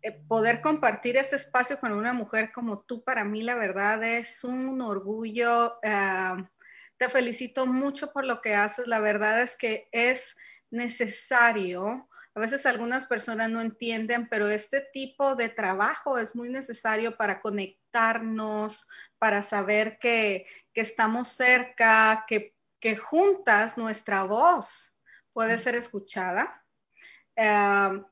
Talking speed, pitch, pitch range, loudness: 130 wpm, 230 Hz, 215-250 Hz, -26 LUFS